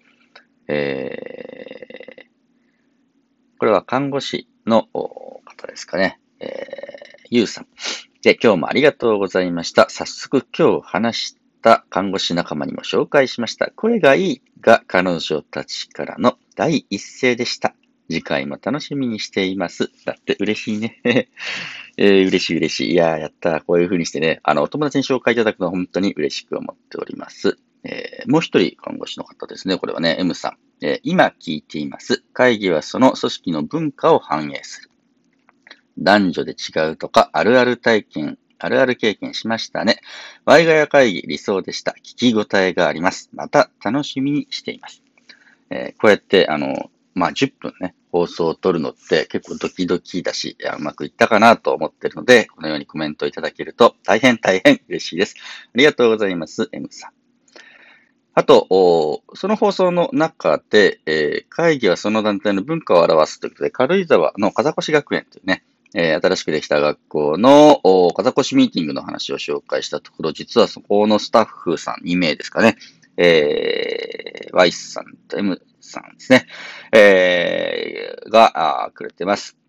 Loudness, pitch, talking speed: -18 LUFS, 145 Hz, 320 characters per minute